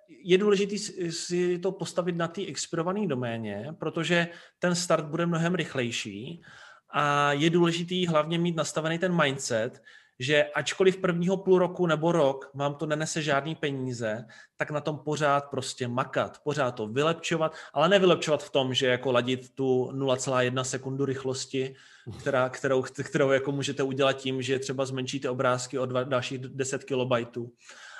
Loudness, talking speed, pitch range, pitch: -27 LUFS, 150 wpm, 130-170 Hz, 140 Hz